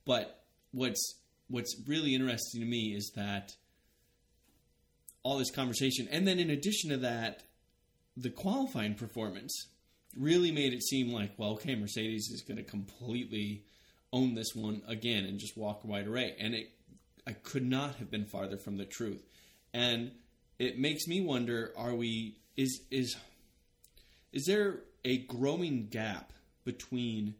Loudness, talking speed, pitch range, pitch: -35 LUFS, 150 wpm, 105-130 Hz, 120 Hz